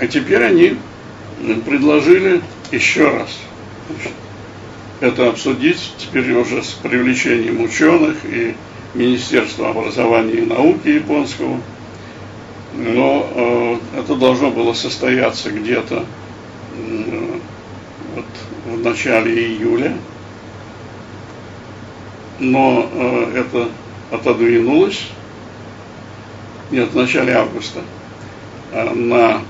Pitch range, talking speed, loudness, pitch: 110-145 Hz, 85 wpm, -16 LUFS, 115 Hz